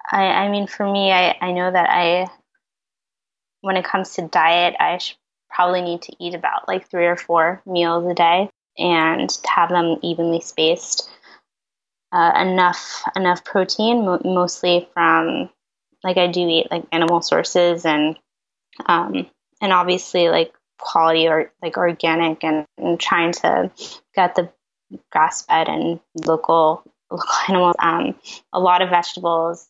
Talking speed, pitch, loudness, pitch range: 145 wpm, 175 Hz, -18 LUFS, 165-180 Hz